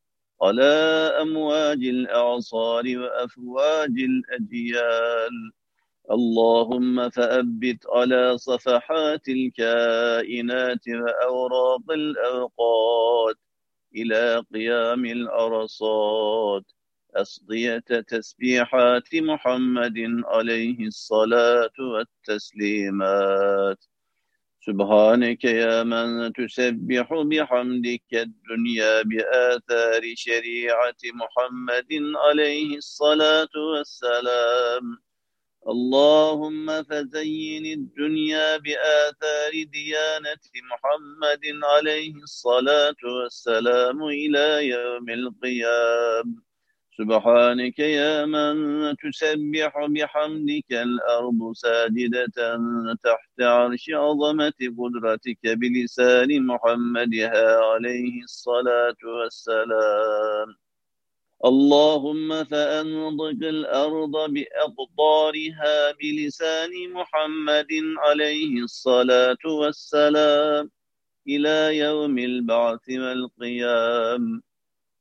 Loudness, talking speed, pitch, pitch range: -22 LUFS, 60 wpm, 125 Hz, 115-150 Hz